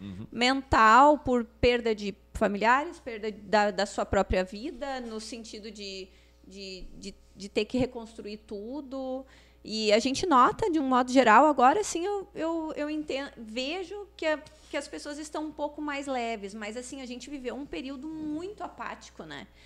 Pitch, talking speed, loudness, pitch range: 255 Hz, 170 wpm, -27 LUFS, 220-300 Hz